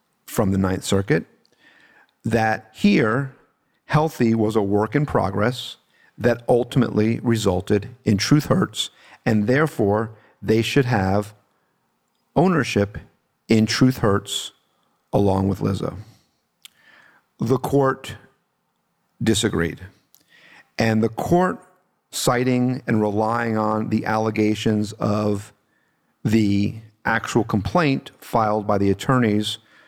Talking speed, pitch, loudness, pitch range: 100 wpm, 110 Hz, -21 LUFS, 105-125 Hz